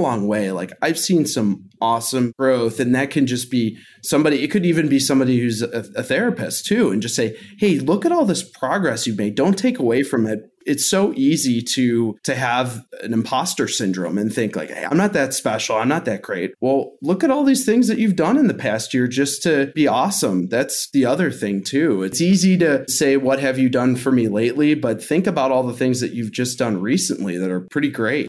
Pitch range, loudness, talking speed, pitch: 115-150 Hz, -19 LUFS, 230 wpm, 130 Hz